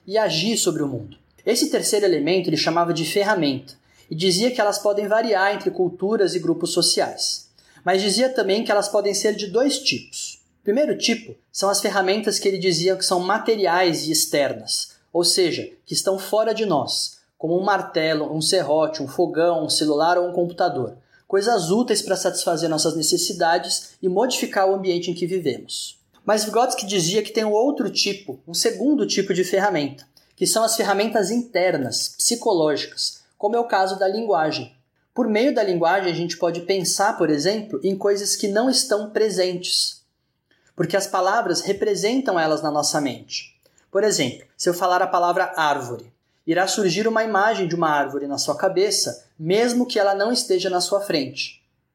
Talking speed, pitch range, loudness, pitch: 180 wpm, 170-210 Hz, -21 LUFS, 190 Hz